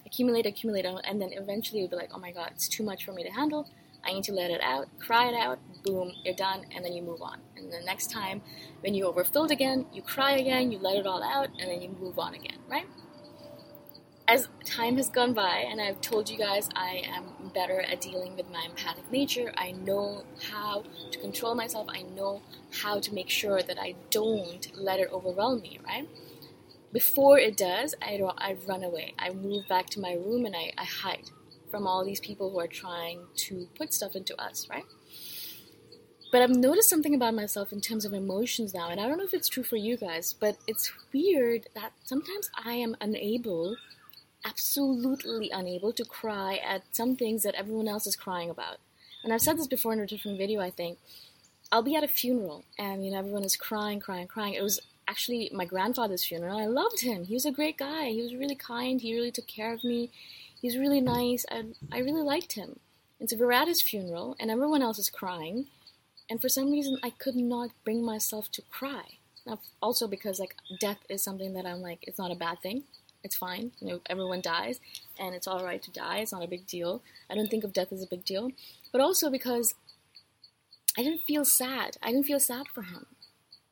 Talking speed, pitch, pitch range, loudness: 215 wpm, 210 Hz, 185-245 Hz, -30 LUFS